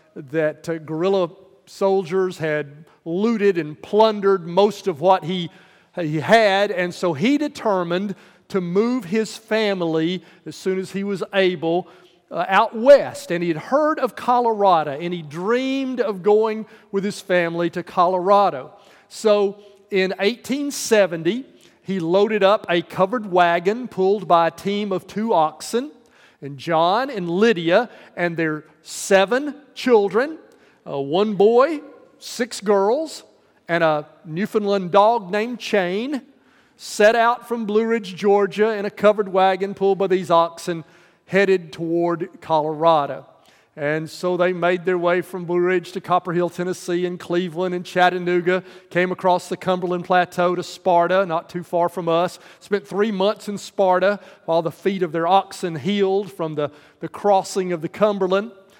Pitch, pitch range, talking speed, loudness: 190 Hz, 175-205 Hz, 150 wpm, -20 LUFS